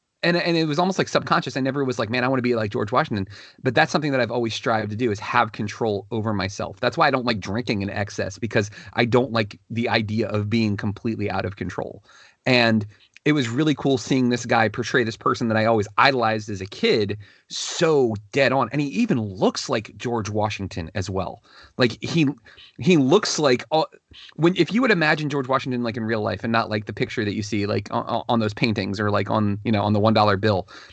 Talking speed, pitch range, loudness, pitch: 235 wpm, 105-130 Hz, -22 LUFS, 115 Hz